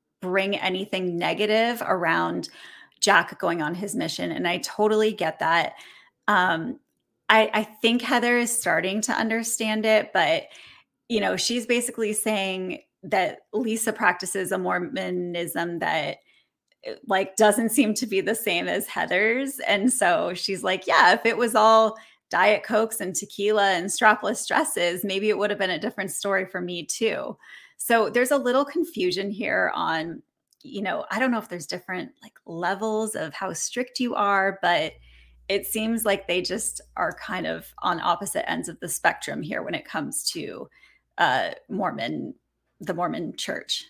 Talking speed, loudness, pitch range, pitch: 165 wpm, -24 LUFS, 190-230 Hz, 210 Hz